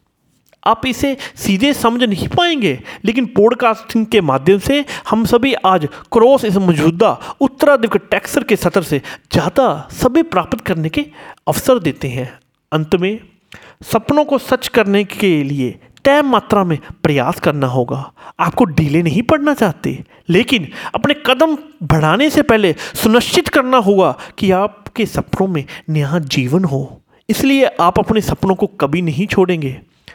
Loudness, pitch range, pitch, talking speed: -15 LUFS, 160-255 Hz, 205 Hz, 145 wpm